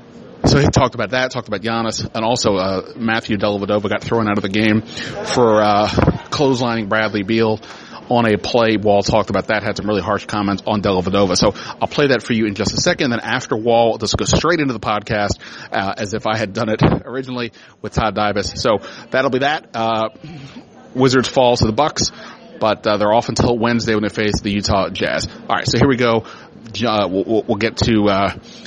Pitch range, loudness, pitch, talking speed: 105-115 Hz, -17 LUFS, 110 Hz, 210 wpm